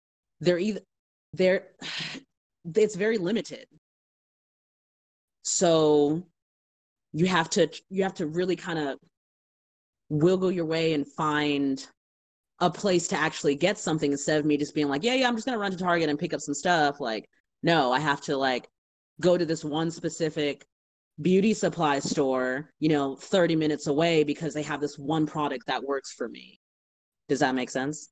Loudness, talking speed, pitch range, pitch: -26 LUFS, 170 wpm, 140-175 Hz, 155 Hz